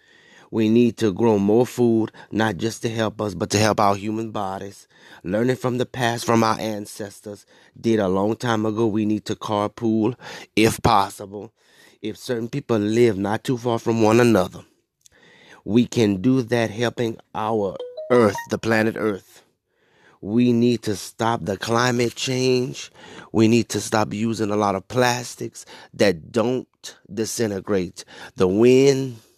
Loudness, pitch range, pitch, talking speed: -21 LUFS, 105-120 Hz, 110 Hz, 155 wpm